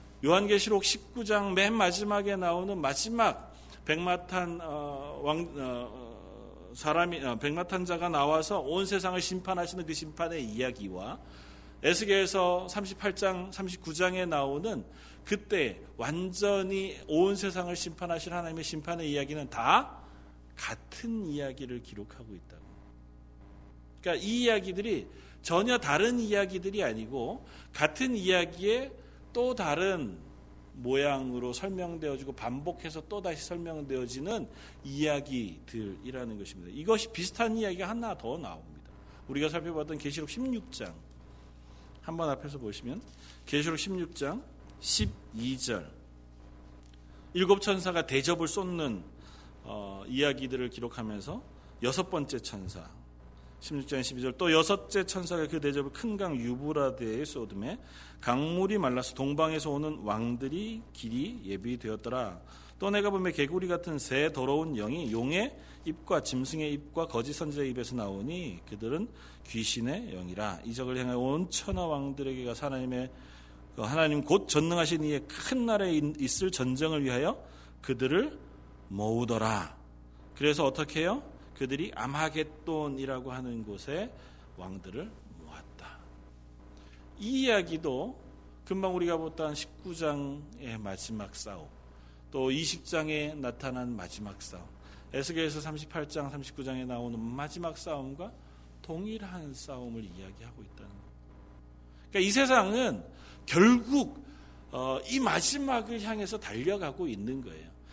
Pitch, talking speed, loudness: 145 Hz, 270 characters per minute, -32 LUFS